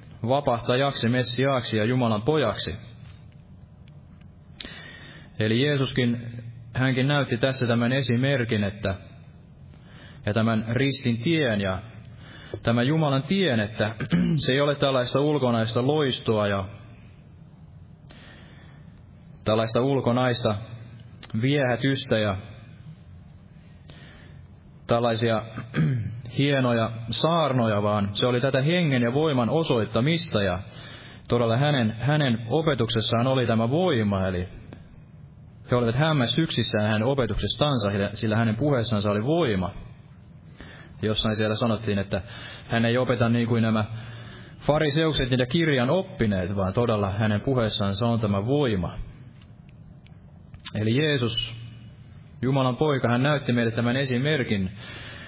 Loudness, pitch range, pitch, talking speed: -24 LUFS, 110-135 Hz, 120 Hz, 100 wpm